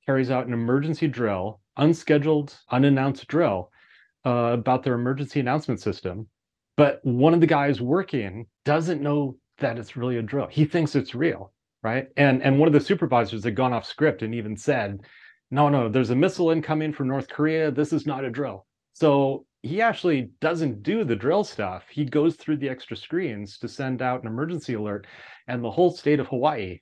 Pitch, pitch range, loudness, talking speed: 135 Hz, 120-150 Hz, -24 LUFS, 190 wpm